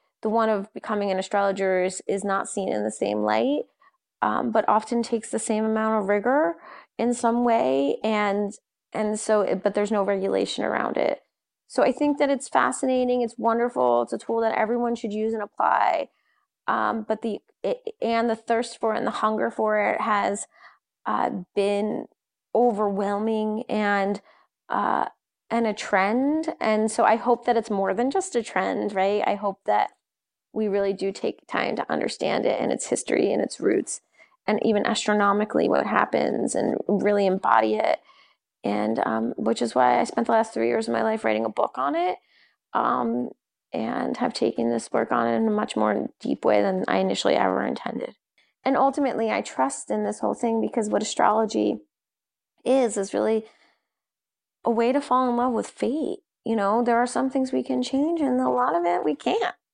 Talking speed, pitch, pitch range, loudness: 190 wpm, 220 Hz, 195-240 Hz, -24 LUFS